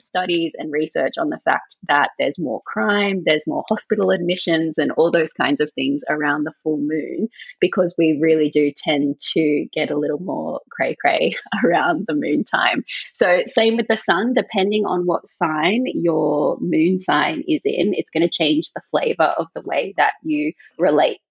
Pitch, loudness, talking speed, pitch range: 170 Hz, -19 LUFS, 185 wpm, 155-210 Hz